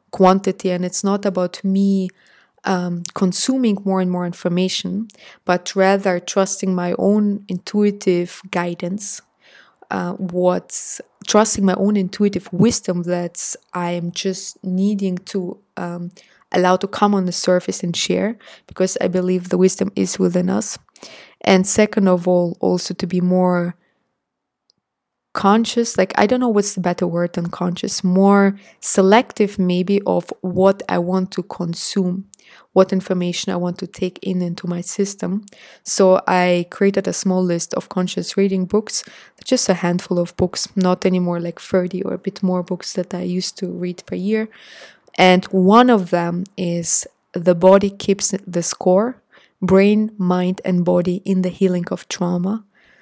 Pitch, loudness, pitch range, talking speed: 185 Hz, -18 LUFS, 180-195 Hz, 155 wpm